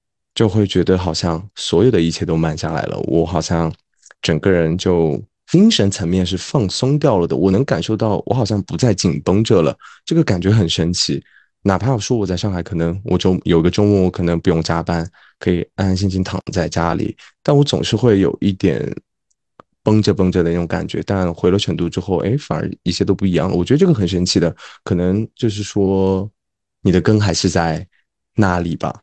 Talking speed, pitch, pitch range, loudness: 295 characters per minute, 95 Hz, 85-105 Hz, -17 LUFS